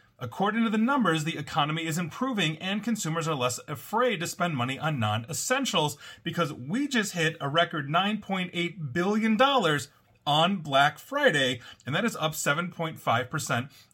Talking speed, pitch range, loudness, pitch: 150 wpm, 150-205 Hz, -27 LUFS, 170 Hz